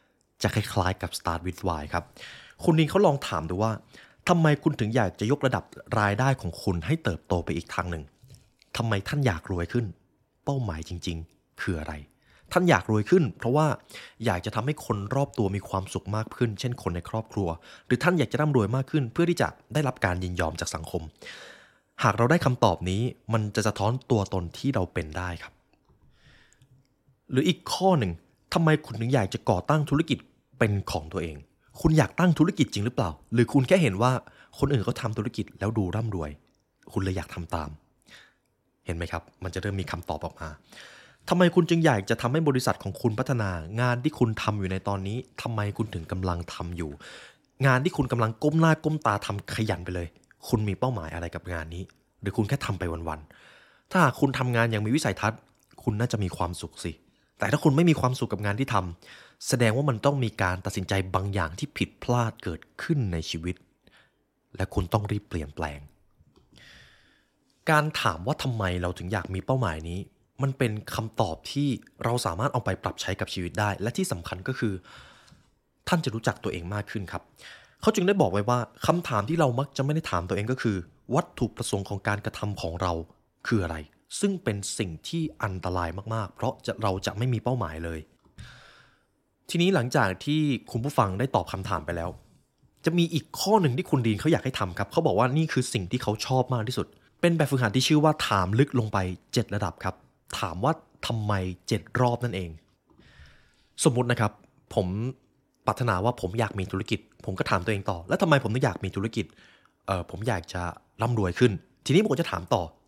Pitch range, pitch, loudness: 95-130 Hz, 110 Hz, -27 LUFS